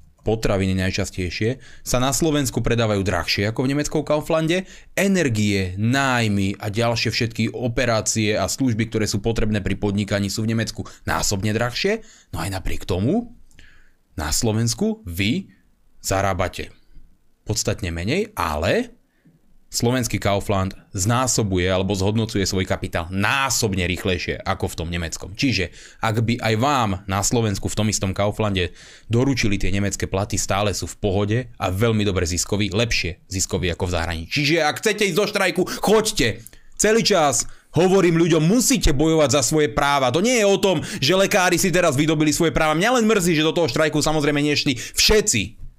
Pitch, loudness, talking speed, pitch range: 110 Hz, -20 LUFS, 155 wpm, 95-150 Hz